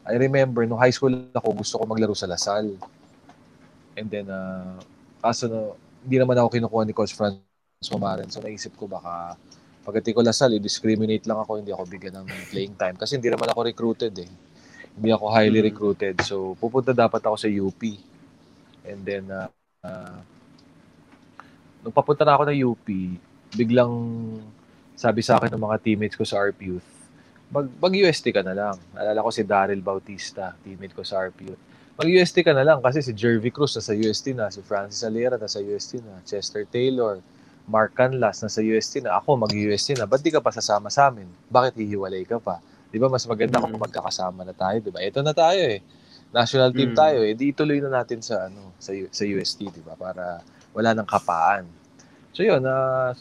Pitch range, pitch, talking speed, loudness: 100-125 Hz, 110 Hz, 195 wpm, -23 LUFS